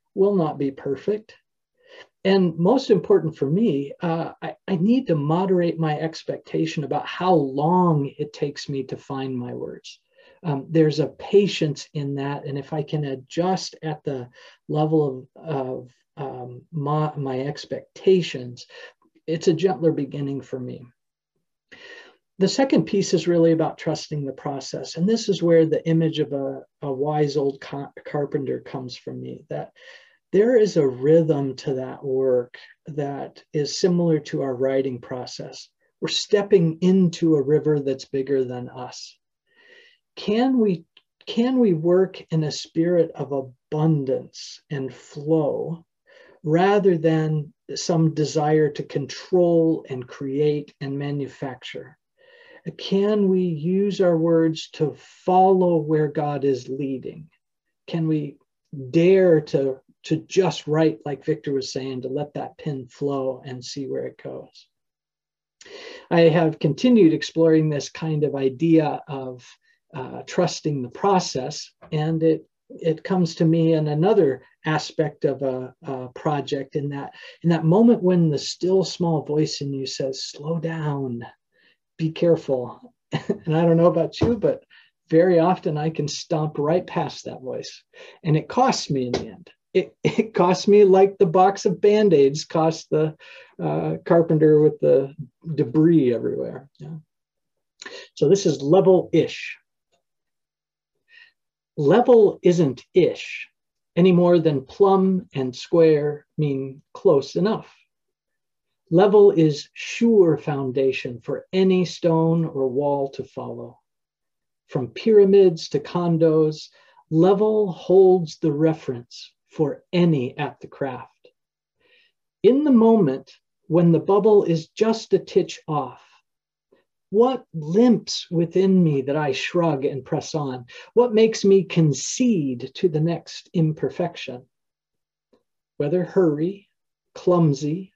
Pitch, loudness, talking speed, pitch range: 160 Hz, -21 LUFS, 135 wpm, 140-185 Hz